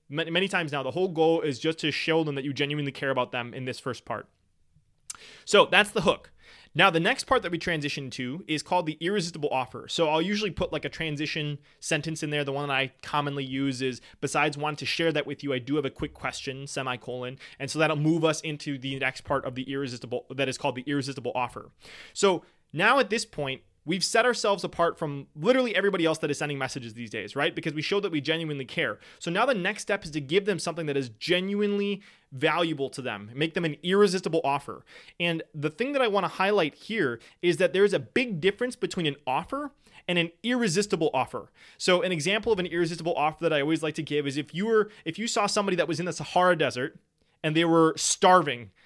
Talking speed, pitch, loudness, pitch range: 230 wpm, 160 Hz, -27 LUFS, 140-180 Hz